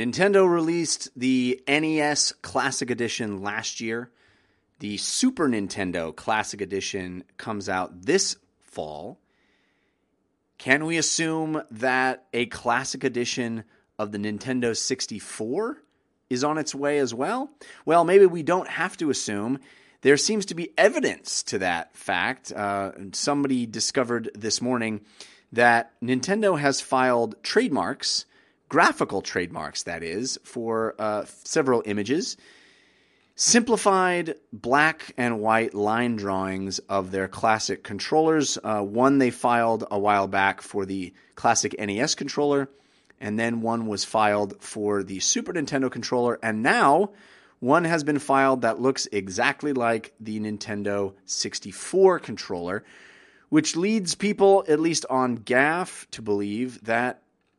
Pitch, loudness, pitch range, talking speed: 120 Hz, -24 LUFS, 105-145 Hz, 130 wpm